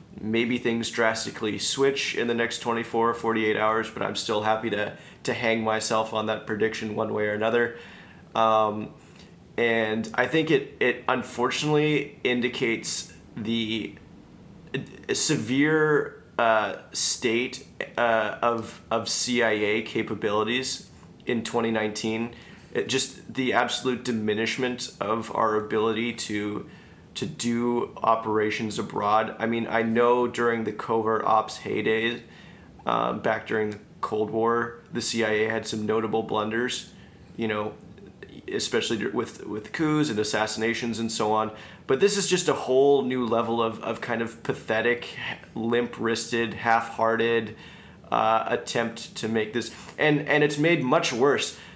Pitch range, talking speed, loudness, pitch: 110-120 Hz, 135 wpm, -26 LUFS, 115 Hz